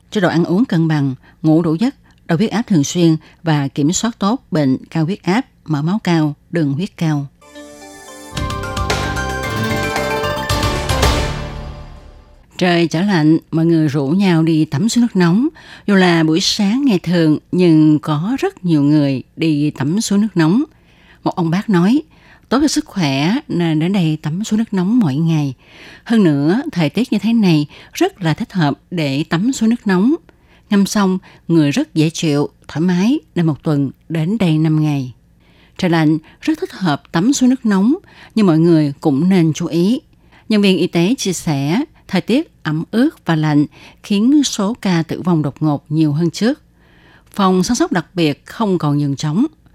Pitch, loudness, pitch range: 165 Hz, -16 LUFS, 150-205 Hz